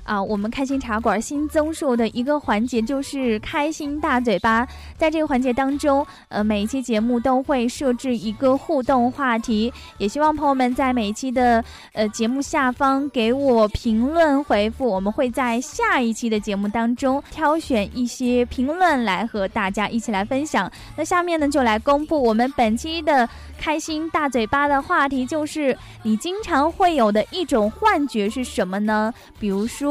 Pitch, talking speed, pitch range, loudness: 255 Hz, 270 characters per minute, 225-290 Hz, -21 LUFS